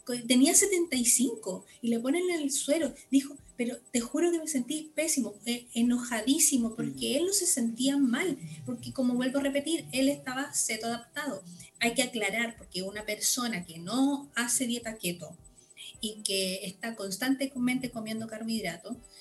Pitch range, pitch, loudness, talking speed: 220-275 Hz, 245 Hz, -29 LUFS, 155 wpm